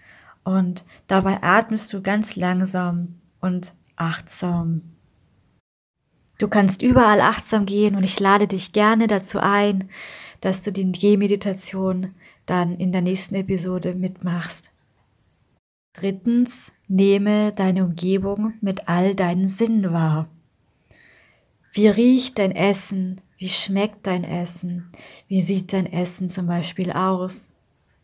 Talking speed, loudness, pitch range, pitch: 115 wpm, -20 LUFS, 180-205 Hz, 190 Hz